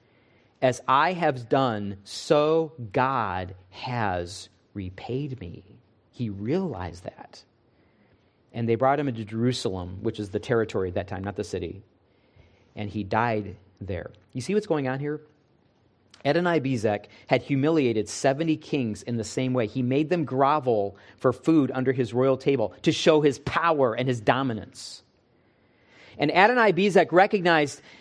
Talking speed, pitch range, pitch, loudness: 150 wpm, 105-140 Hz, 120 Hz, -25 LUFS